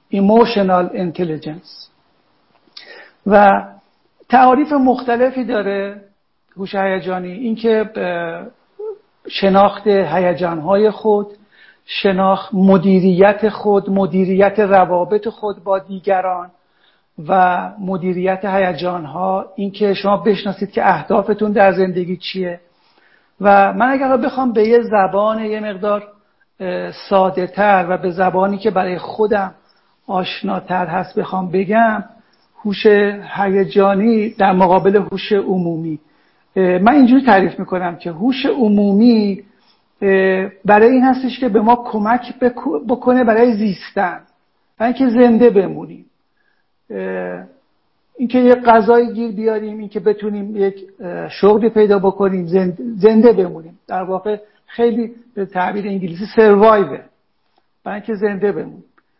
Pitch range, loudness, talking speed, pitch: 190-220 Hz, -15 LUFS, 105 wpm, 200 Hz